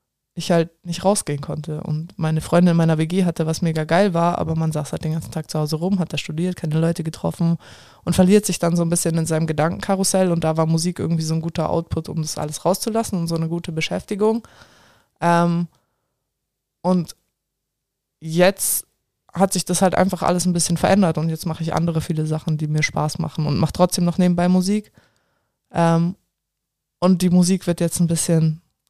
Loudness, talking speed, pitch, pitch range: -20 LUFS, 200 wpm, 170 Hz, 160-180 Hz